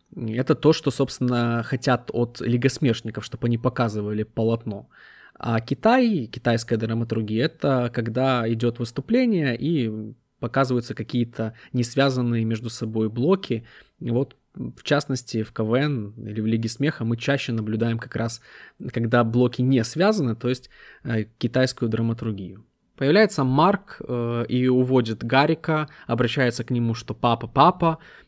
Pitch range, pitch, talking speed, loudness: 115-135 Hz, 120 Hz, 125 wpm, -23 LUFS